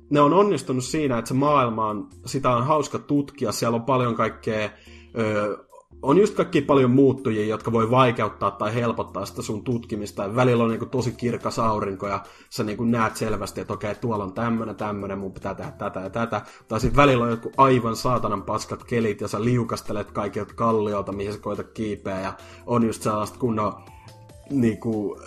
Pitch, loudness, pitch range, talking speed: 115 Hz, -24 LUFS, 105-125 Hz, 190 wpm